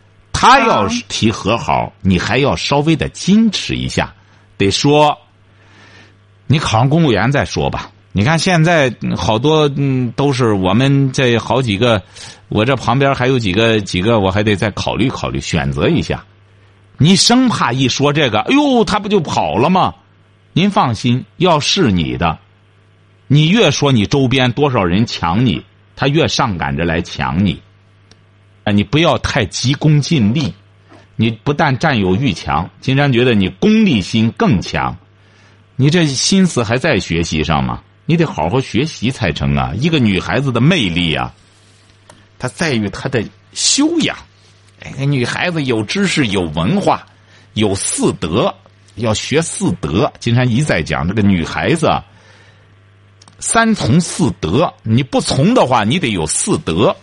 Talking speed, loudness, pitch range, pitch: 215 characters per minute, -14 LUFS, 95-145 Hz, 110 Hz